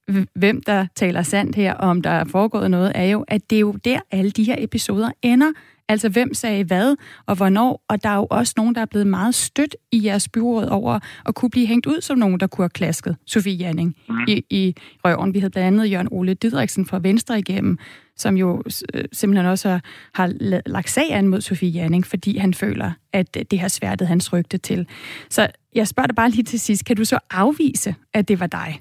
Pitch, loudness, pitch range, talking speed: 200 Hz, -20 LUFS, 185-230 Hz, 225 wpm